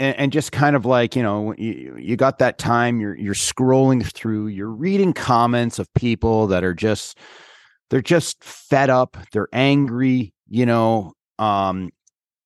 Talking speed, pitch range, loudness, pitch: 160 wpm, 105-130 Hz, -19 LUFS, 120 Hz